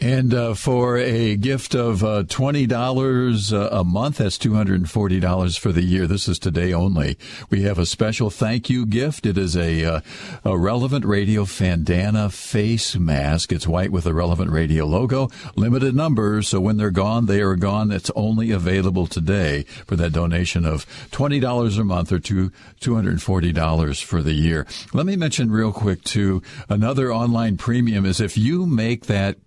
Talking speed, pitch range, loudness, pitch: 170 wpm, 90-120 Hz, -20 LUFS, 105 Hz